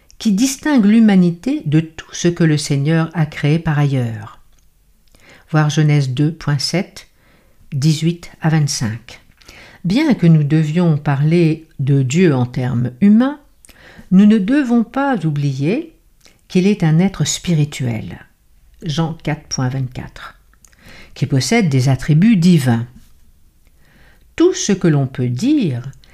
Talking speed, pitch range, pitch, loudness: 120 wpm, 135-185 Hz, 155 Hz, -15 LUFS